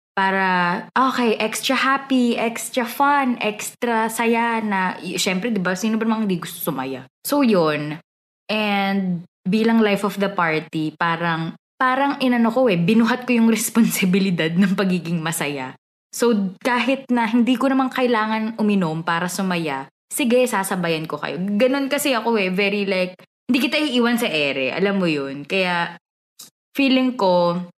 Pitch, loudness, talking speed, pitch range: 205 Hz, -20 LUFS, 150 wpm, 175-240 Hz